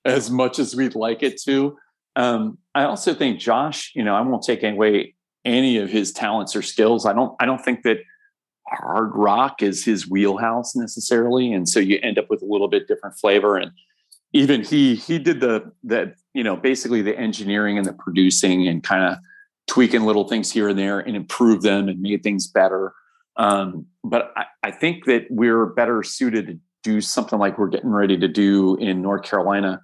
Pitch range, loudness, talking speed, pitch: 100-130 Hz, -20 LUFS, 200 wpm, 115 Hz